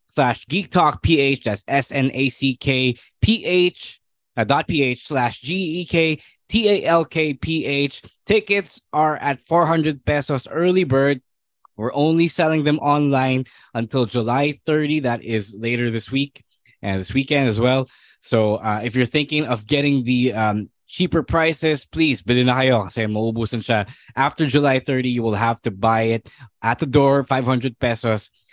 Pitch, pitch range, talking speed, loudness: 135 Hz, 120-150 Hz, 135 wpm, -20 LUFS